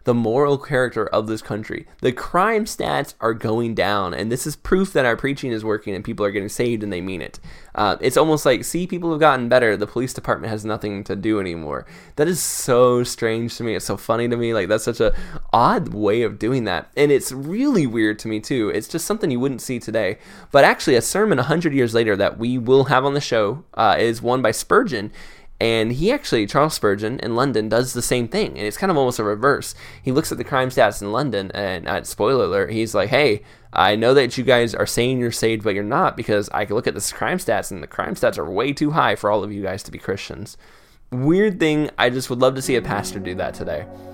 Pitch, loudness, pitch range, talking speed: 120 Hz, -20 LUFS, 110-140 Hz, 250 wpm